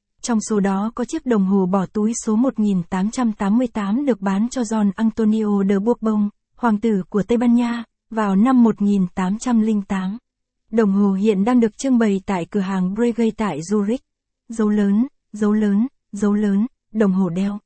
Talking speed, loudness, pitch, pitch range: 165 wpm, -19 LUFS, 215 Hz, 200-230 Hz